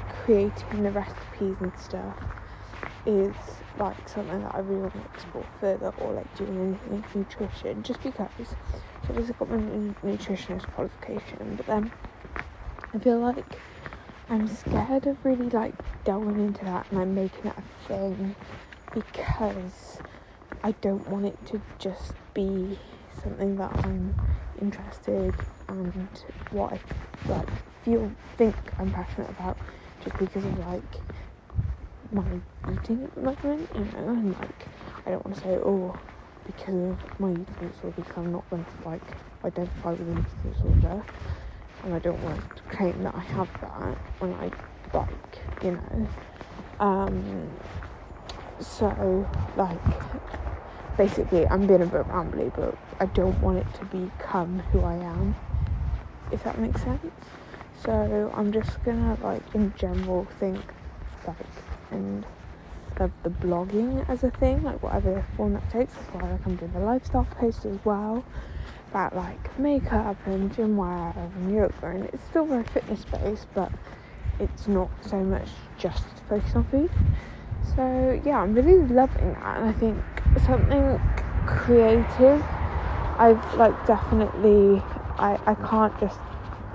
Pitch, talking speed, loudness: 190 Hz, 150 wpm, -27 LUFS